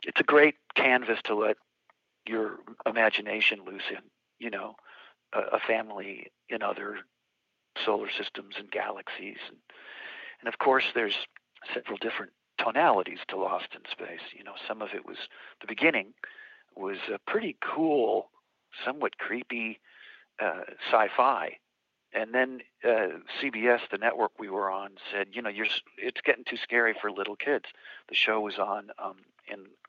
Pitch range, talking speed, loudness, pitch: 105-120 Hz, 155 wpm, -29 LUFS, 110 Hz